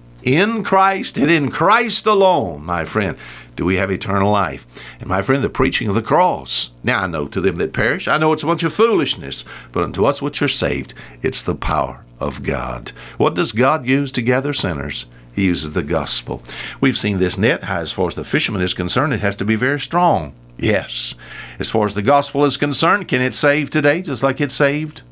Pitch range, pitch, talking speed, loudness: 90-145 Hz, 125 Hz, 215 wpm, -17 LUFS